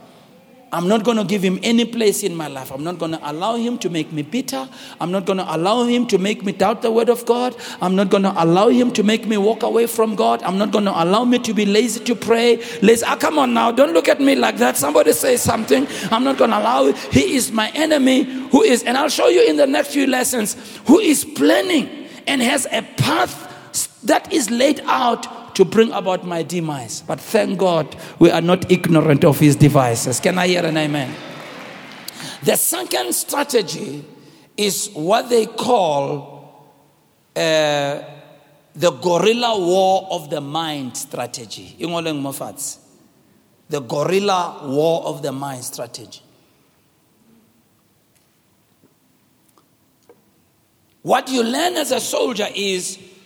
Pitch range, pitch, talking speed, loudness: 165-240 Hz, 210 Hz, 165 wpm, -17 LUFS